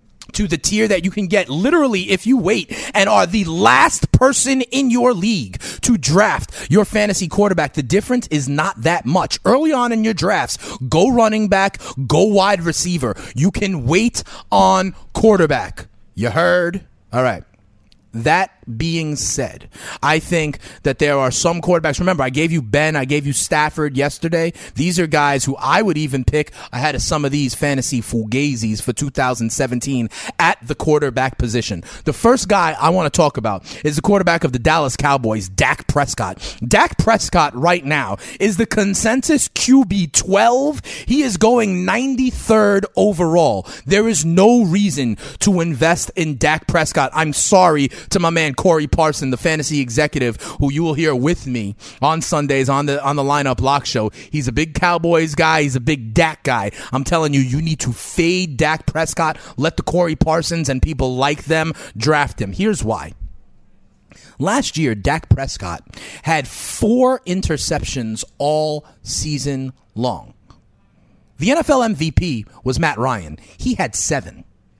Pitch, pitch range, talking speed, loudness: 155 Hz, 135-190 Hz, 165 wpm, -17 LUFS